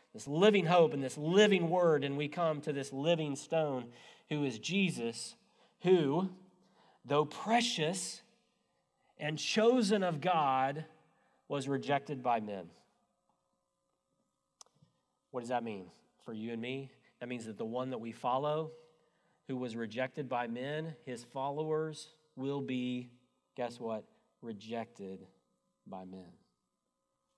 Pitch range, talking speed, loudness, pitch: 120-160 Hz, 125 wpm, -34 LUFS, 140 Hz